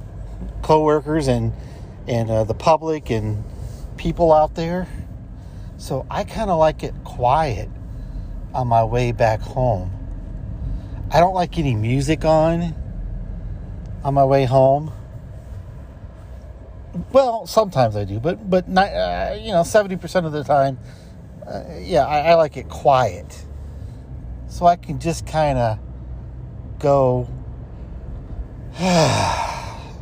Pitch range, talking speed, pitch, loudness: 105-160 Hz, 120 wpm, 125 Hz, -19 LUFS